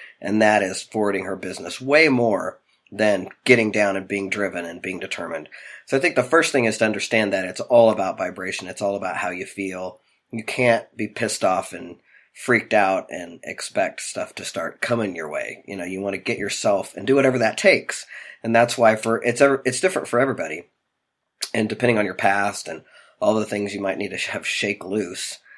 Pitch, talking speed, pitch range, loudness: 105 Hz, 210 wpm, 95-120 Hz, -21 LUFS